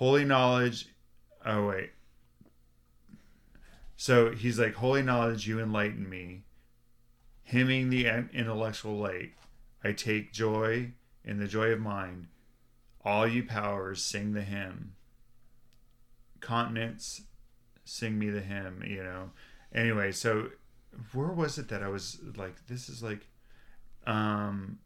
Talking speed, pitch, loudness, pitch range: 120 wpm, 115 Hz, -31 LUFS, 100-120 Hz